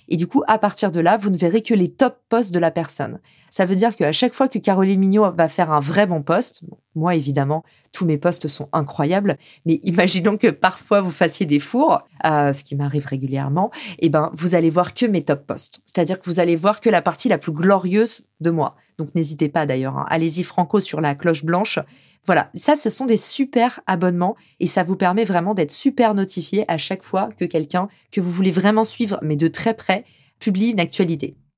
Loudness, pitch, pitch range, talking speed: -19 LUFS, 180 Hz, 165-210 Hz, 220 wpm